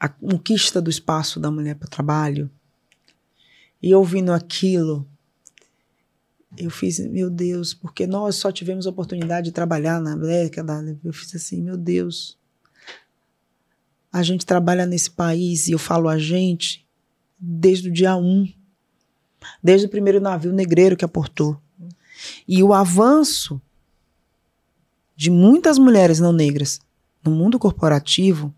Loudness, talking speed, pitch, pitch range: -18 LUFS, 135 wpm, 175 Hz, 155-185 Hz